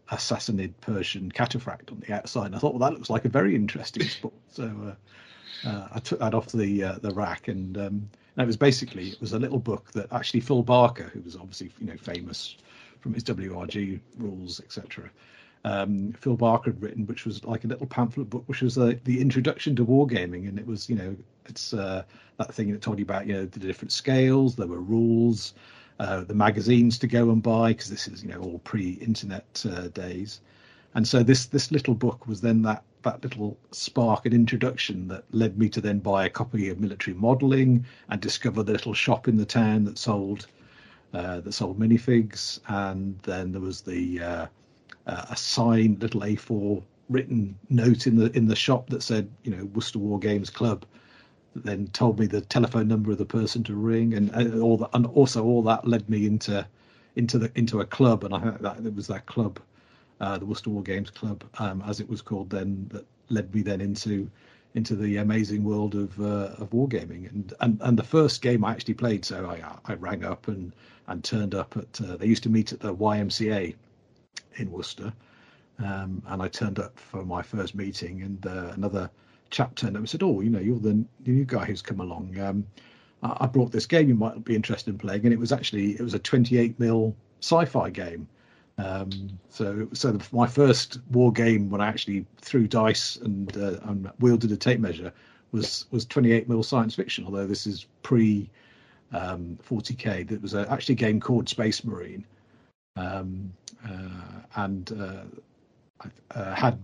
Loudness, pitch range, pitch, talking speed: -26 LUFS, 100-120 Hz, 110 Hz, 205 wpm